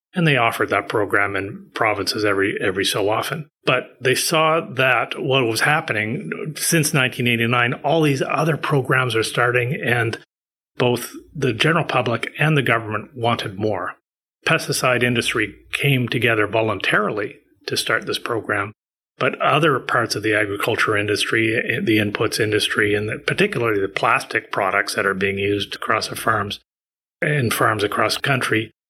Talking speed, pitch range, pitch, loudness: 150 wpm, 110-145 Hz, 120 Hz, -19 LUFS